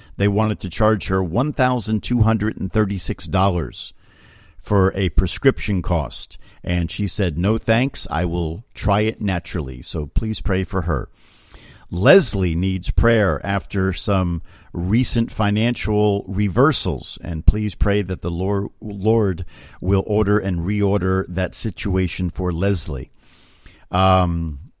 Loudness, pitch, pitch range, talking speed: -20 LUFS, 95 Hz, 90-105 Hz, 115 wpm